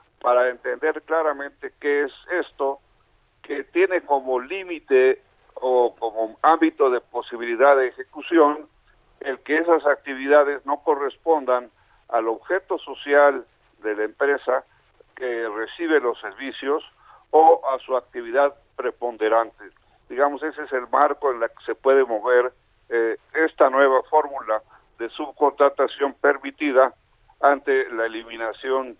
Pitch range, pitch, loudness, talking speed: 120-160 Hz, 140 Hz, -22 LUFS, 120 wpm